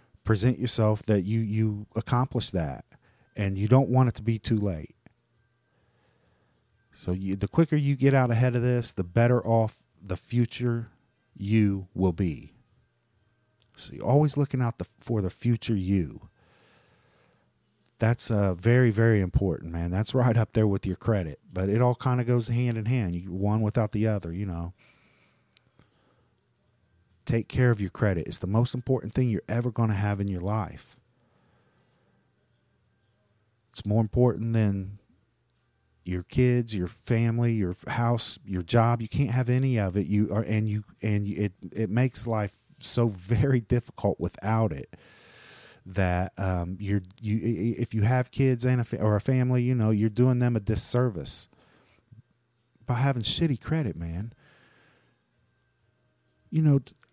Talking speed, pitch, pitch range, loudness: 160 wpm, 110 Hz, 100-120 Hz, -26 LUFS